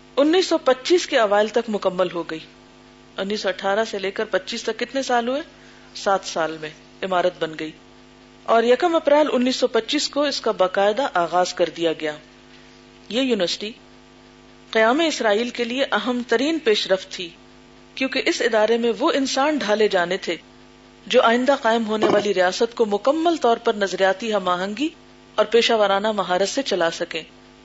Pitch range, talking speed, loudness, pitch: 180-250 Hz, 175 wpm, -21 LUFS, 210 Hz